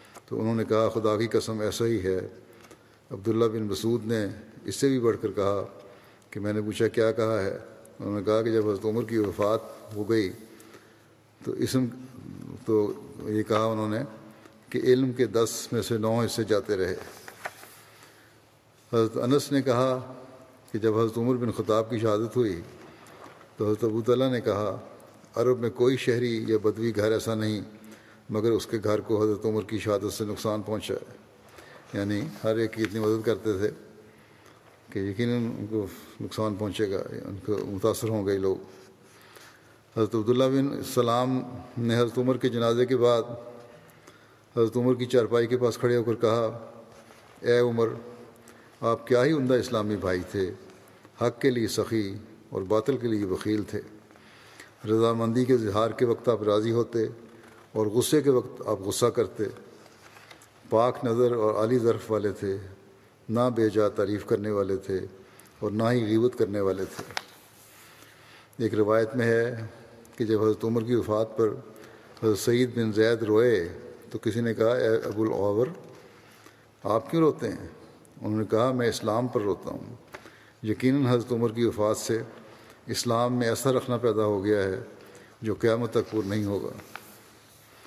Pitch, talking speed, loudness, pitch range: 115 Hz, 170 wpm, -27 LUFS, 110-120 Hz